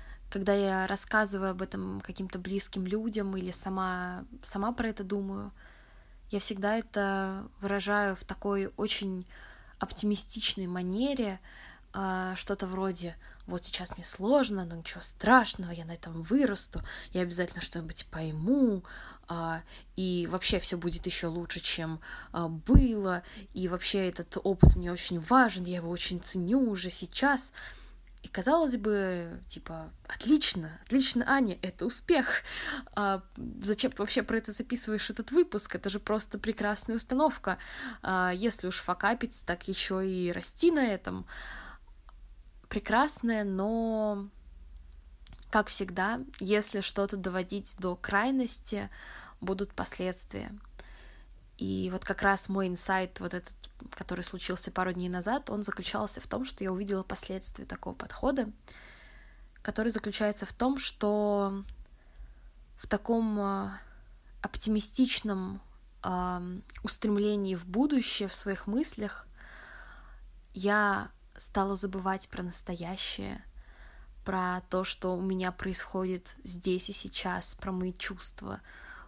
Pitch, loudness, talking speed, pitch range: 195 Hz, -31 LUFS, 120 wpm, 180-215 Hz